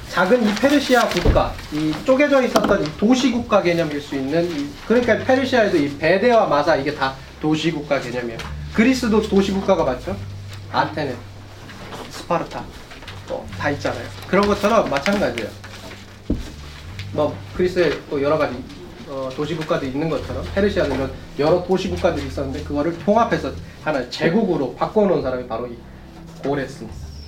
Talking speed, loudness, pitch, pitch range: 350 characters per minute, -20 LUFS, 160 Hz, 125-205 Hz